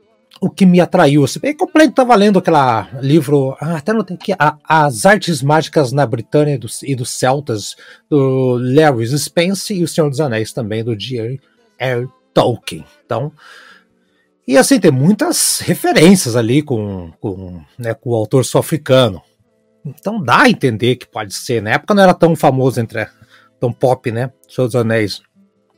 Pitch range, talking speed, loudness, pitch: 120-170 Hz, 170 wpm, -14 LUFS, 140 Hz